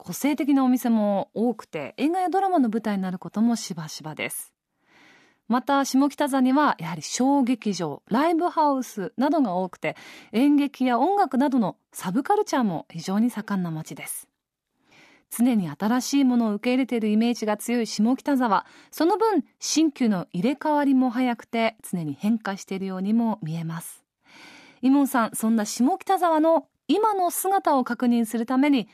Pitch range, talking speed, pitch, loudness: 210-290 Hz, 330 characters per minute, 245 Hz, -24 LUFS